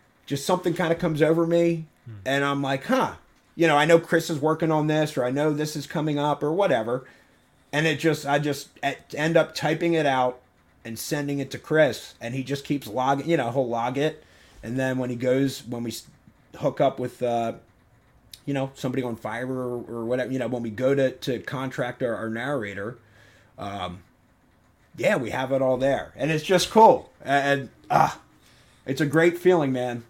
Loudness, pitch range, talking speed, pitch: -24 LUFS, 120-155 Hz, 205 wpm, 135 Hz